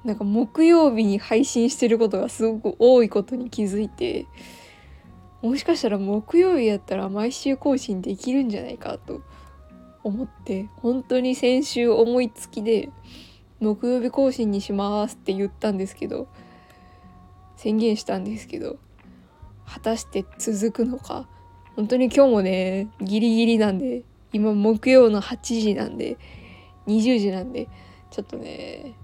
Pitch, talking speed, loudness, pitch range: 215 Hz, 275 characters per minute, -22 LUFS, 195-245 Hz